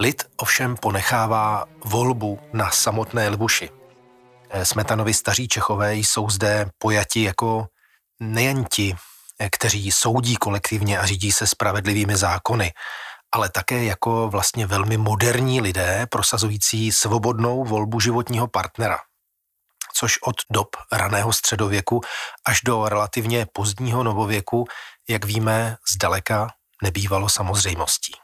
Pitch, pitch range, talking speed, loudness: 110 Hz, 100-115 Hz, 110 wpm, -21 LUFS